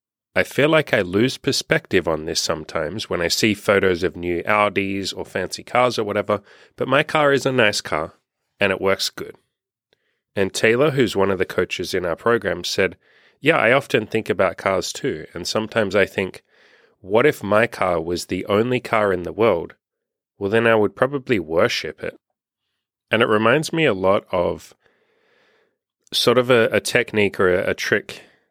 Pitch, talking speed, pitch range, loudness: 110 Hz, 185 wpm, 100-140 Hz, -20 LUFS